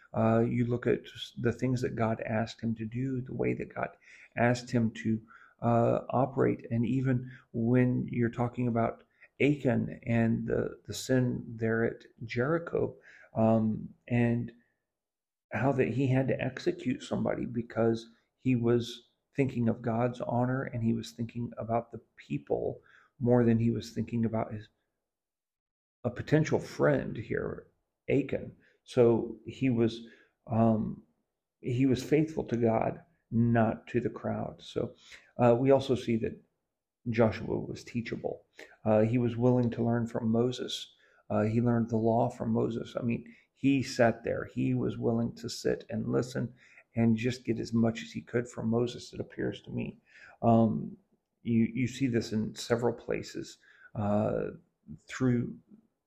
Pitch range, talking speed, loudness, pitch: 115-125 Hz, 155 wpm, -31 LUFS, 115 Hz